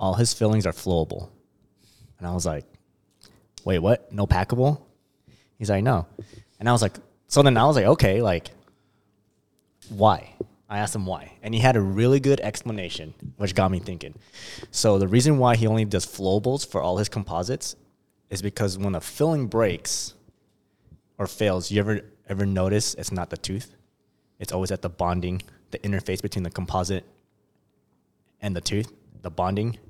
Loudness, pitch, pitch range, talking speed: -24 LUFS, 100 Hz, 95-110 Hz, 175 wpm